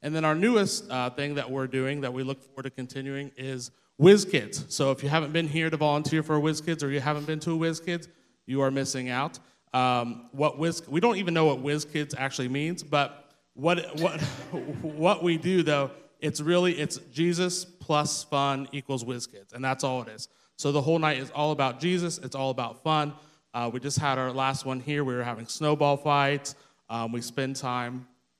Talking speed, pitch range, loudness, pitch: 210 wpm, 130-155 Hz, -28 LUFS, 145 Hz